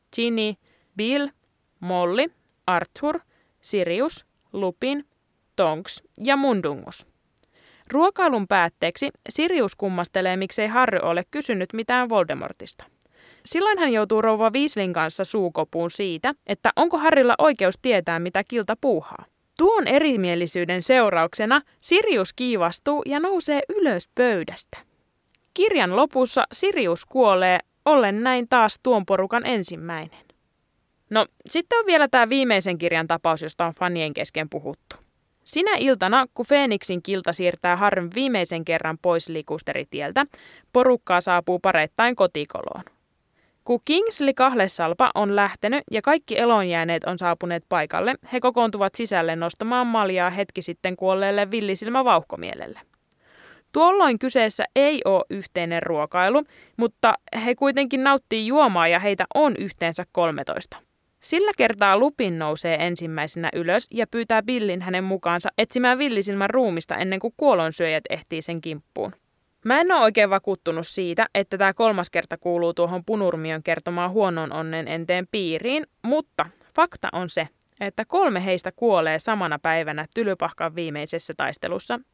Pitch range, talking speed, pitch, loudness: 175-255 Hz, 125 wpm, 200 Hz, -22 LUFS